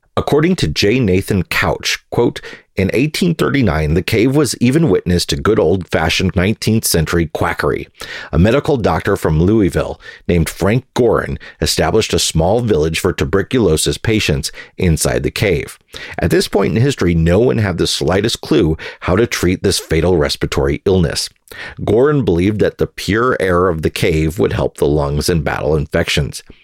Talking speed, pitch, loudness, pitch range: 160 wpm, 85 Hz, -15 LUFS, 80-100 Hz